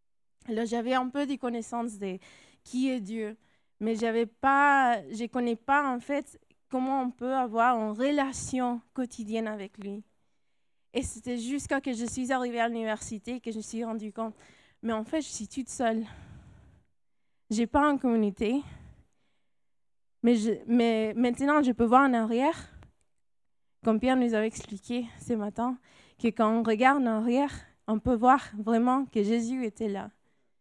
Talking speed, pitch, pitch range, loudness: 170 wpm, 235 Hz, 225-255 Hz, -29 LUFS